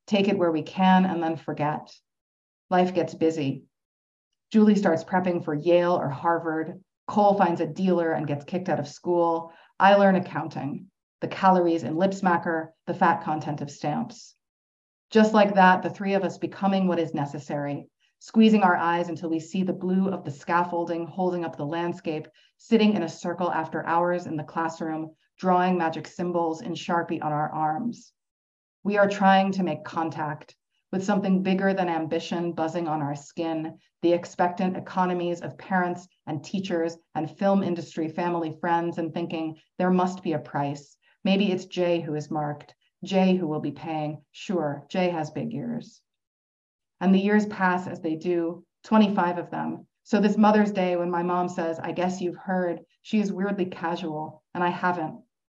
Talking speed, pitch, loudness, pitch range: 175 wpm, 170 Hz, -25 LUFS, 155-185 Hz